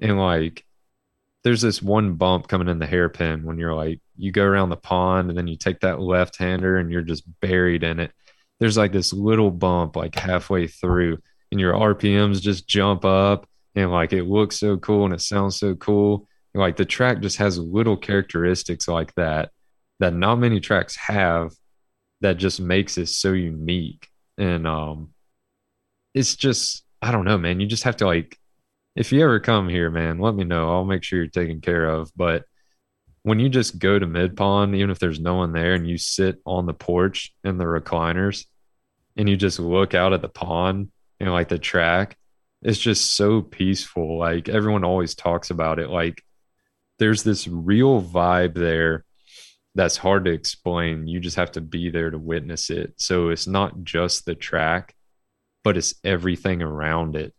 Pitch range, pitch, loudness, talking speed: 85-100 Hz, 90 Hz, -22 LUFS, 190 wpm